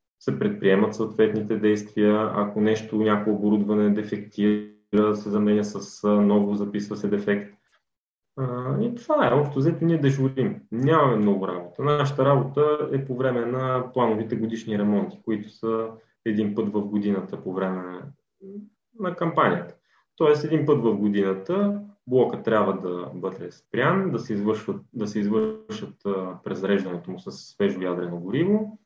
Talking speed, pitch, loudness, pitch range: 140 wpm, 110 Hz, -24 LUFS, 105-135 Hz